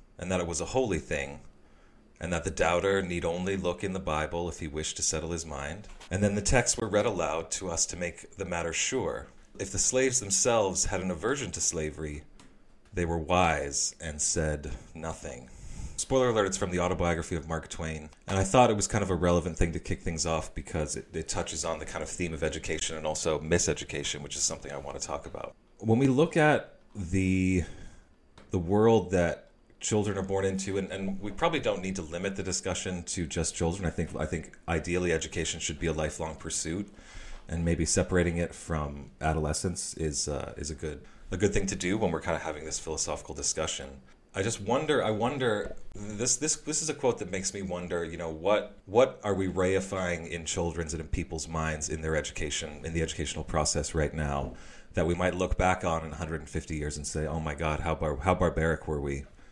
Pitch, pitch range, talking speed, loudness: 85 Hz, 80-95 Hz, 215 wpm, -30 LUFS